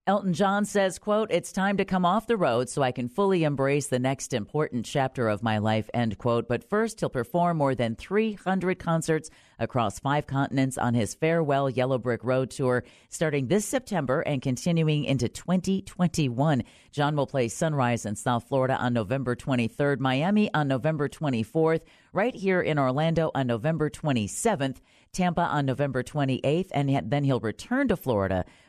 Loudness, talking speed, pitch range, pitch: -26 LUFS, 170 wpm, 125-170 Hz, 140 Hz